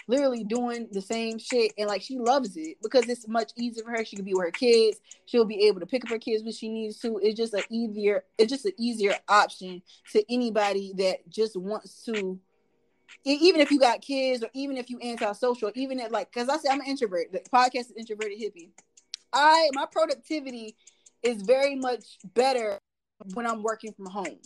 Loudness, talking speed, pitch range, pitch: -27 LUFS, 210 wpm, 210-255 Hz, 230 Hz